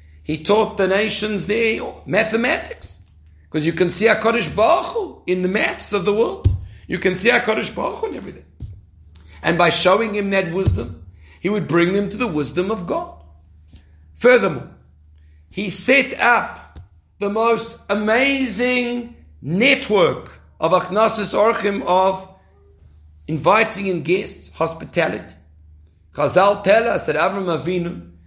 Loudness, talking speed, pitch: -18 LUFS, 135 wpm, 180 Hz